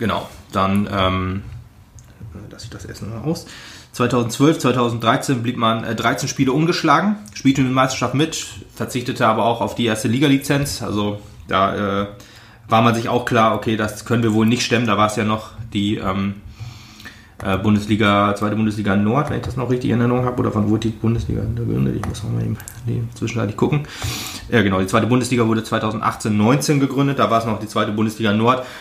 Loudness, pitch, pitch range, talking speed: -19 LUFS, 115 Hz, 105-120 Hz, 195 wpm